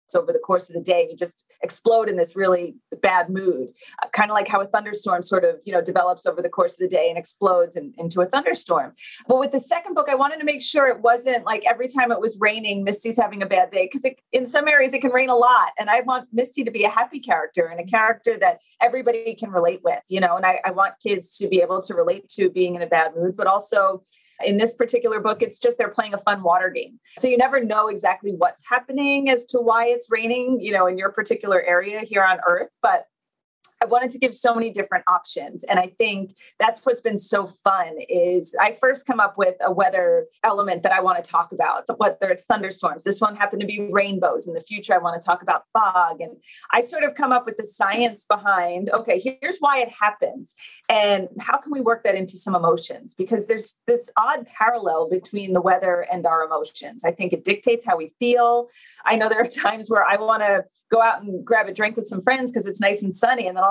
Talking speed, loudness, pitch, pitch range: 245 wpm, -20 LUFS, 215 Hz, 185-250 Hz